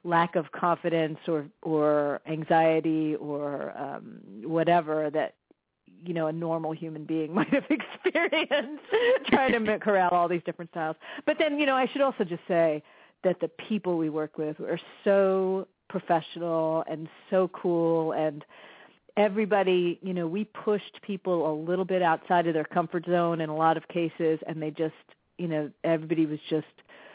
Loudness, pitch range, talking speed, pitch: -28 LUFS, 160-190 Hz, 165 wpm, 170 Hz